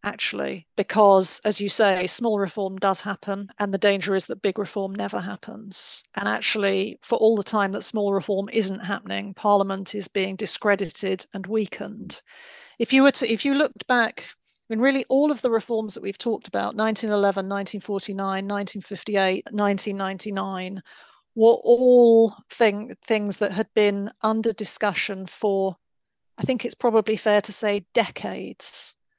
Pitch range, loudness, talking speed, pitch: 195-220 Hz, -23 LUFS, 155 wpm, 205 Hz